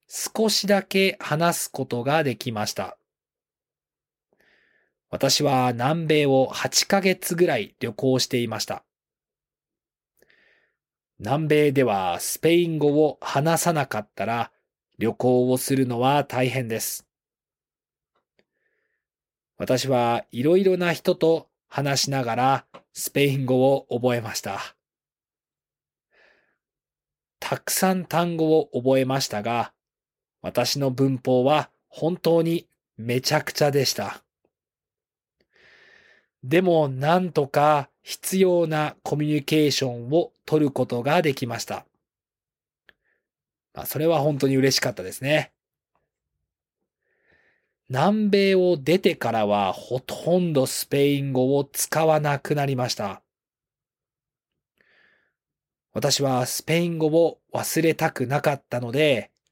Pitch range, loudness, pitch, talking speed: 130-165 Hz, -23 LUFS, 145 Hz, 205 characters per minute